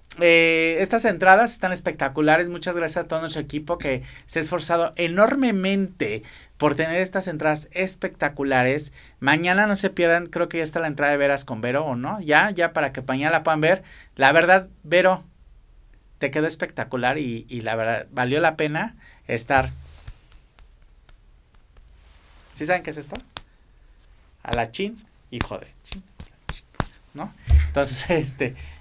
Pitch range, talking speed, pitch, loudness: 135-180 Hz, 150 wpm, 160 Hz, -22 LUFS